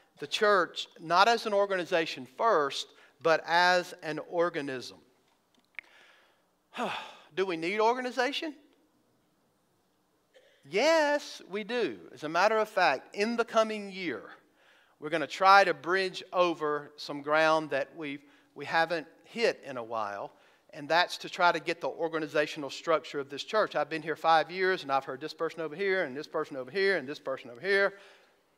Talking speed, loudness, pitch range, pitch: 160 wpm, -29 LUFS, 150-200 Hz, 170 Hz